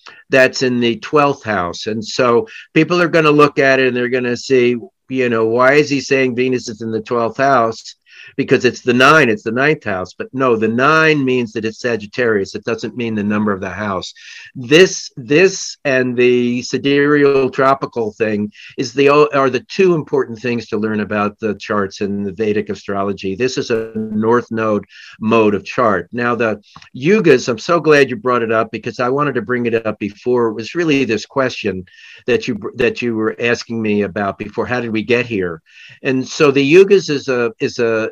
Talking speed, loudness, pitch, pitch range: 205 wpm, -15 LUFS, 120 Hz, 110-135 Hz